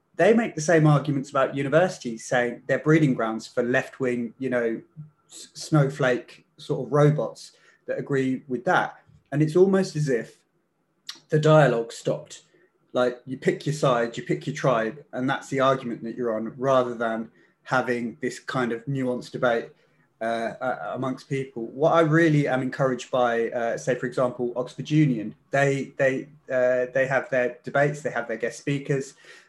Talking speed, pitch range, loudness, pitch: 170 wpm, 125-145 Hz, -24 LUFS, 130 Hz